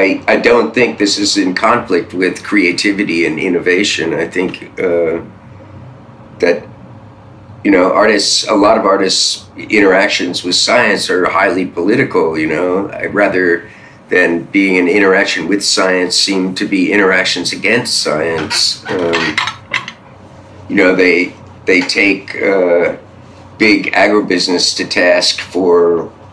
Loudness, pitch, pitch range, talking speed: -12 LUFS, 95 Hz, 90-105 Hz, 130 wpm